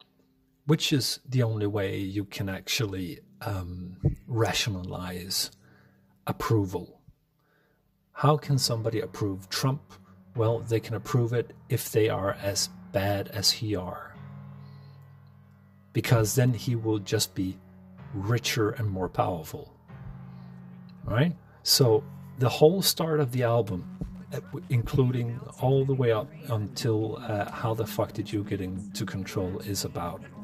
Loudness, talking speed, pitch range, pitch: -28 LUFS, 130 wpm, 100-140 Hz, 115 Hz